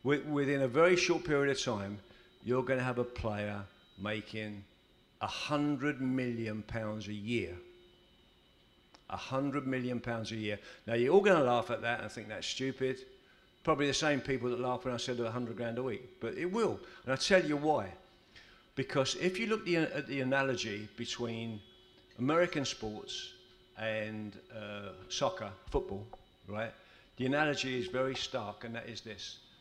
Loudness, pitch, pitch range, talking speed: -34 LUFS, 125 Hz, 110-145 Hz, 170 wpm